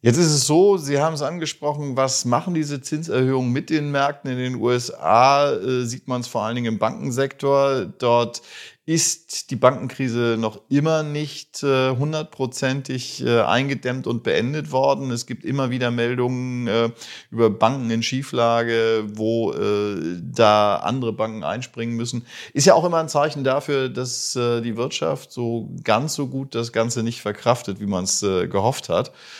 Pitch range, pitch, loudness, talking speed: 115-140 Hz, 125 Hz, -21 LUFS, 170 wpm